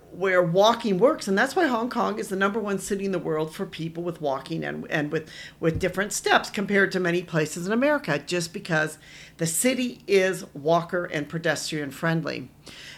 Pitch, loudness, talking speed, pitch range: 175 Hz, -25 LUFS, 190 wpm, 160-200 Hz